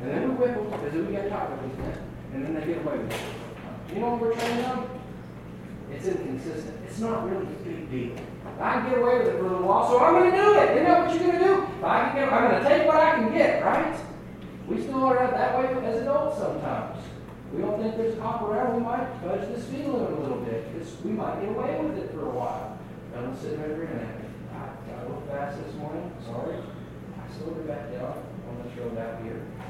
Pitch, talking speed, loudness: 230 Hz, 240 wpm, -26 LUFS